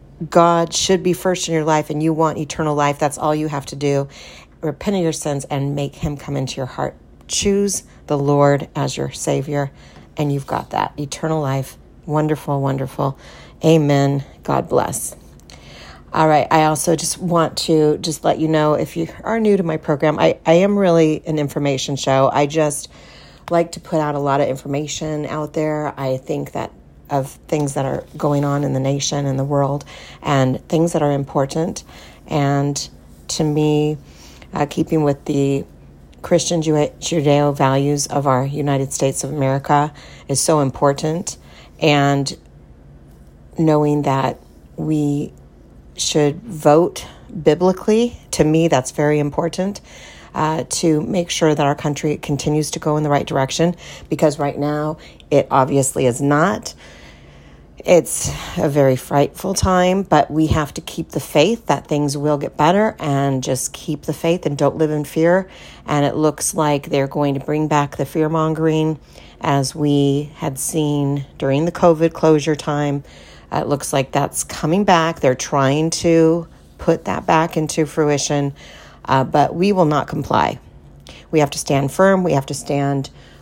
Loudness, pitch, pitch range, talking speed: -18 LUFS, 150 Hz, 140-160 Hz, 170 wpm